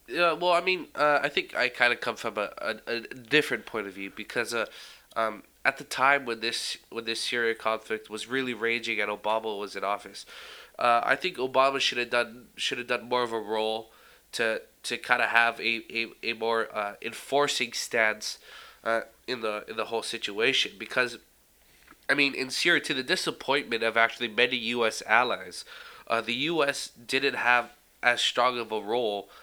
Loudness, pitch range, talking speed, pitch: -27 LUFS, 110-130 Hz, 195 wpm, 120 Hz